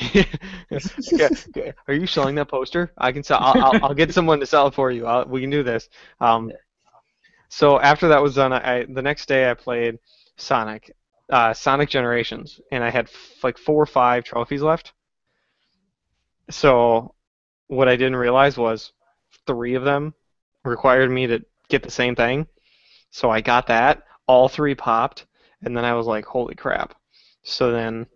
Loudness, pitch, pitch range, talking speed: -20 LUFS, 130 Hz, 120-145 Hz, 175 wpm